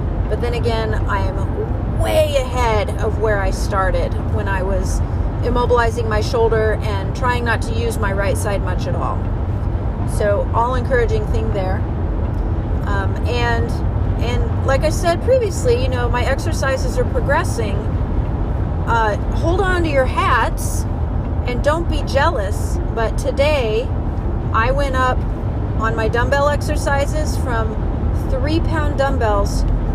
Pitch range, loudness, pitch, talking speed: 90-110 Hz, -19 LUFS, 100 Hz, 135 wpm